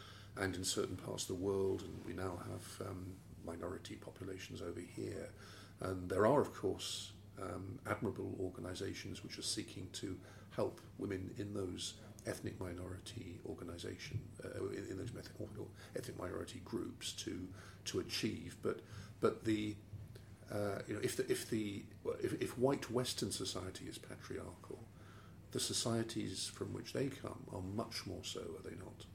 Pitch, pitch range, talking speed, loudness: 100 Hz, 95-110 Hz, 155 wpm, -43 LUFS